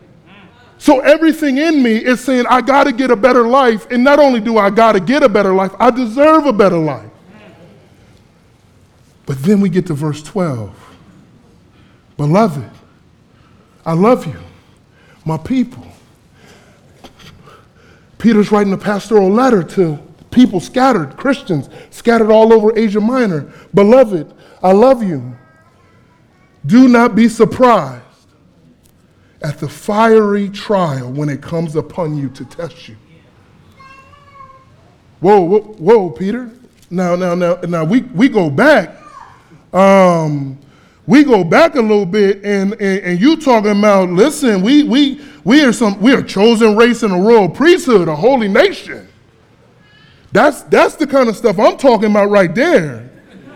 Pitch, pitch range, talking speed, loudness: 210 Hz, 165-245 Hz, 145 wpm, -12 LUFS